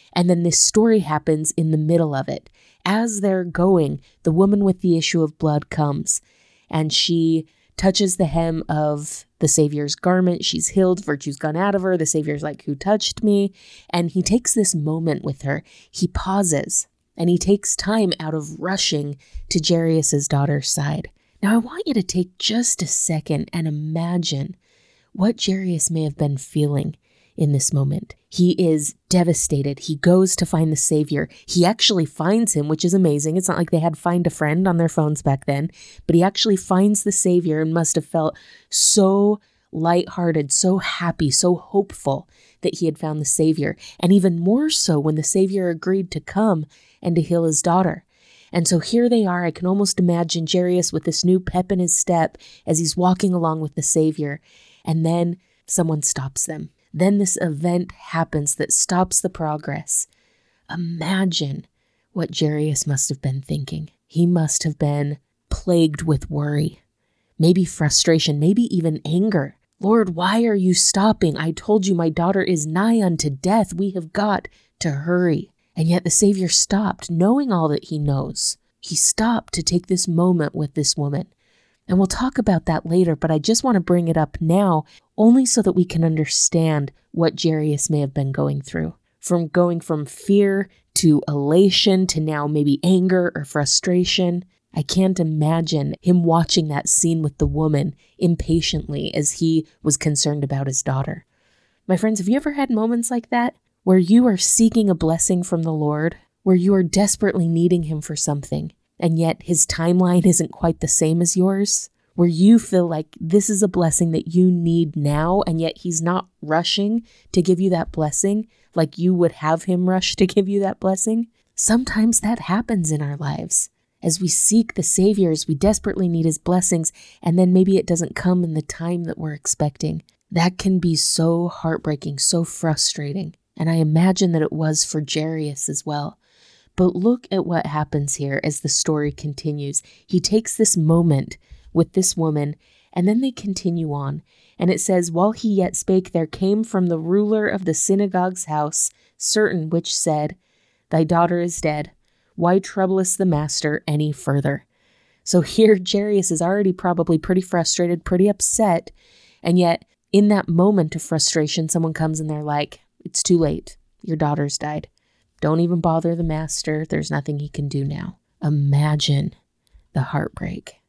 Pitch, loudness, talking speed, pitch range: 170 Hz, -19 LUFS, 180 wpm, 155-190 Hz